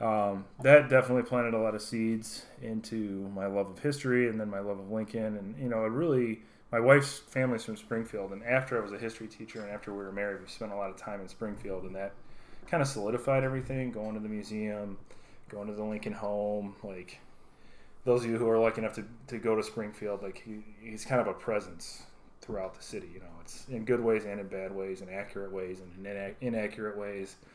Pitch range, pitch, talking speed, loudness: 100-115 Hz, 110 Hz, 225 wpm, -32 LUFS